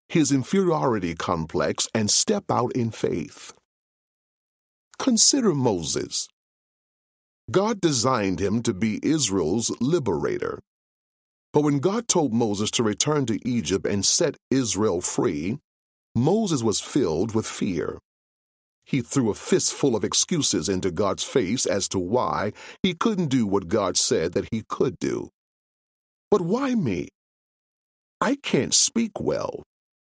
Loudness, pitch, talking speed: -23 LUFS, 120 Hz, 130 wpm